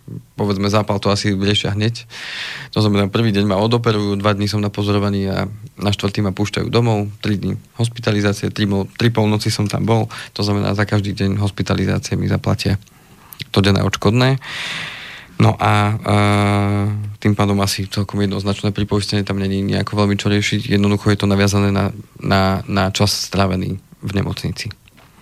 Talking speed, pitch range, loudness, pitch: 160 wpm, 100-105 Hz, -18 LUFS, 105 Hz